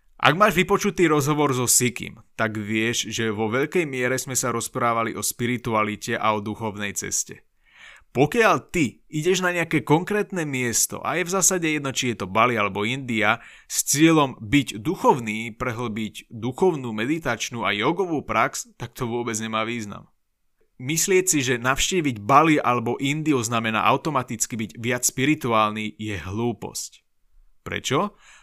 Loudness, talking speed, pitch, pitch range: -22 LUFS, 145 wpm, 125 Hz, 110-150 Hz